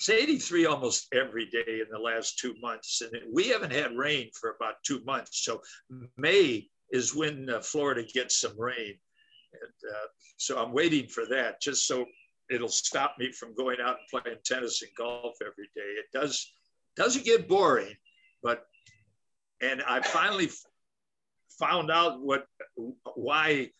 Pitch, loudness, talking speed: 140 Hz, -29 LUFS, 155 wpm